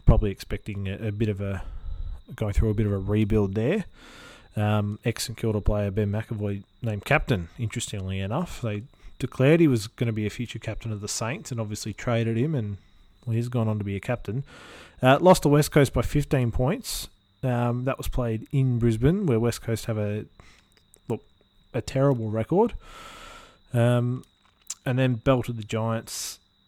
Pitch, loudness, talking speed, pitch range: 115 Hz, -26 LUFS, 180 wpm, 105-130 Hz